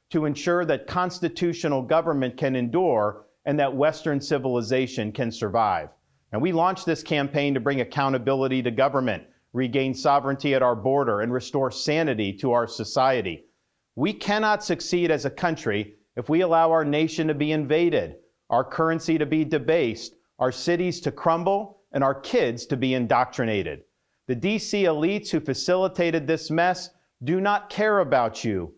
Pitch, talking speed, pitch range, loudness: 145 Hz, 155 wpm, 130-170 Hz, -24 LUFS